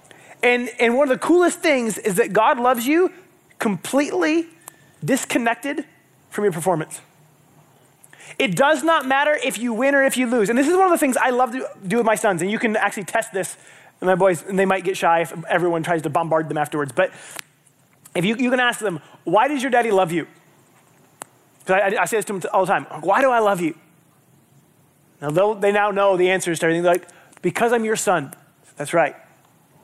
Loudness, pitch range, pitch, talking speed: -20 LUFS, 165-245 Hz, 195 Hz, 215 wpm